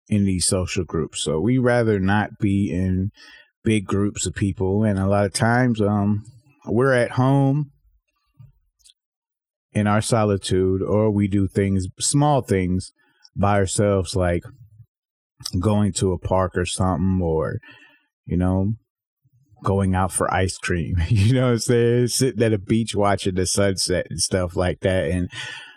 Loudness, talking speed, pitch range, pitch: -21 LUFS, 155 wpm, 95-120 Hz, 100 Hz